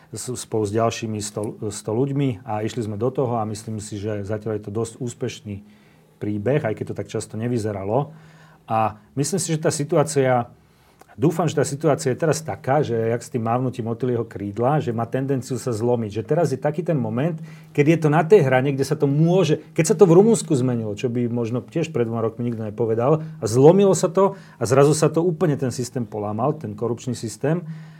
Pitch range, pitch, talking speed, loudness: 115-155 Hz, 125 Hz, 210 wpm, -21 LUFS